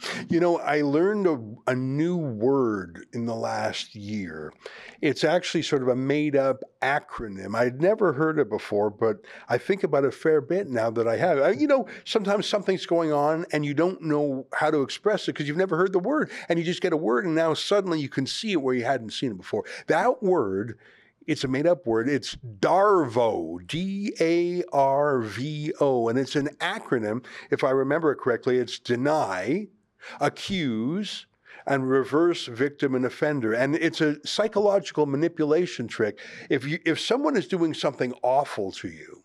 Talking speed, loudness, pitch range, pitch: 190 wpm, -25 LUFS, 130-175 Hz, 150 Hz